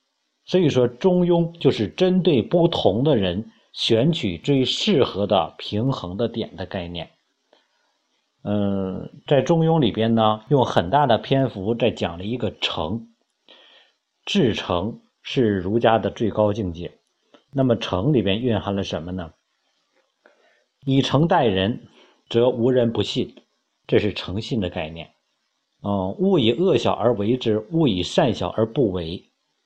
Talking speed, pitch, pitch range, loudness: 195 characters per minute, 115 Hz, 100-135 Hz, -21 LUFS